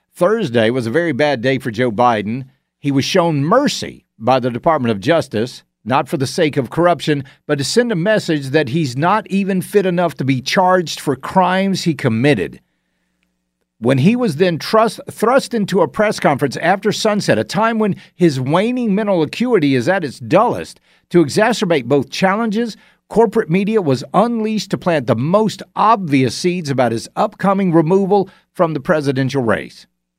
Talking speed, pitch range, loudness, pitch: 175 wpm, 135-200 Hz, -16 LUFS, 170 Hz